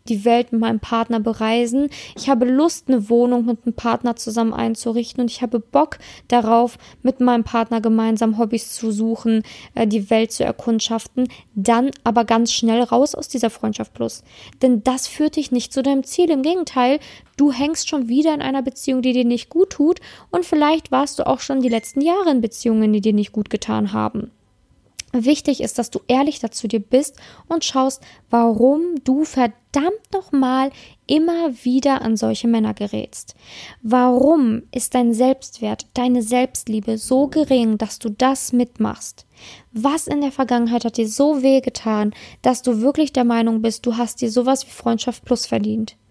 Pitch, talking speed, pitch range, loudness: 245 Hz, 175 wpm, 225-270 Hz, -19 LUFS